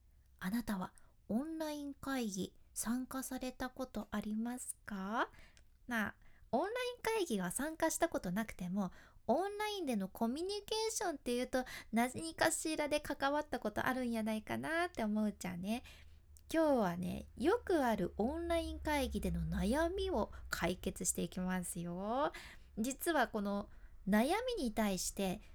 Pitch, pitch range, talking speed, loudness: 245 Hz, 205-315 Hz, 305 characters per minute, -38 LUFS